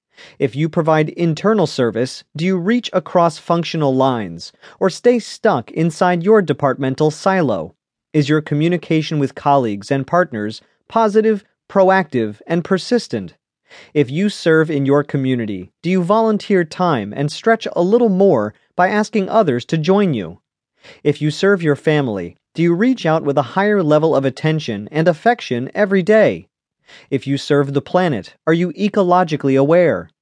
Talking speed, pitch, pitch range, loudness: 155 wpm, 160 Hz, 140-190 Hz, -17 LUFS